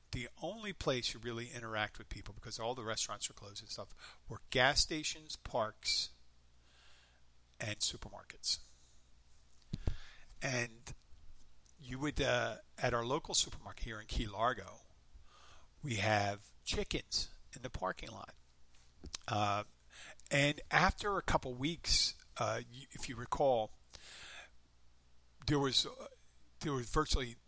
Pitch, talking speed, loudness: 105 Hz, 125 wpm, -37 LUFS